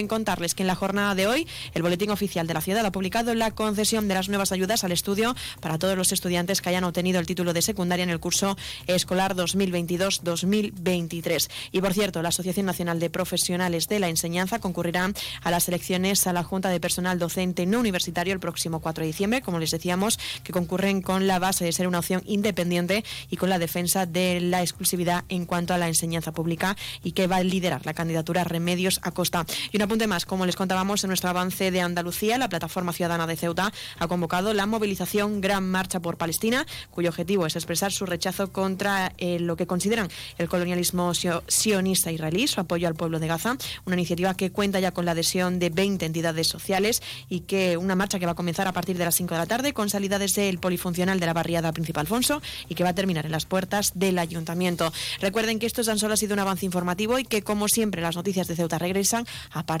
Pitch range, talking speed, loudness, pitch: 175-195 Hz, 220 wpm, -25 LUFS, 180 Hz